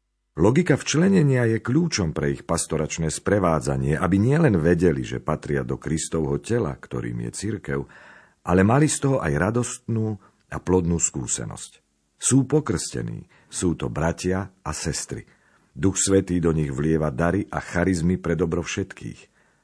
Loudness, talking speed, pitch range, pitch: -23 LUFS, 140 wpm, 75-110 Hz, 90 Hz